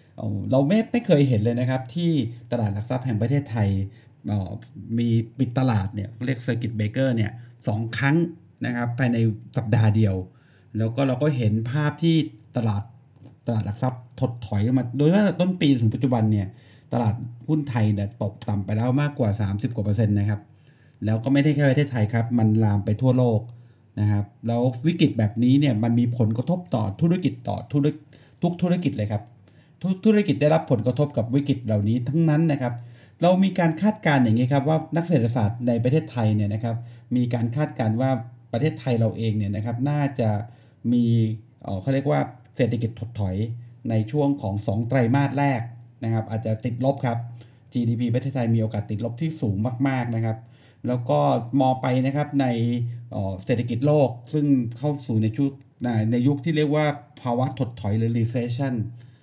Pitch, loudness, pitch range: 120 Hz, -24 LUFS, 110-140 Hz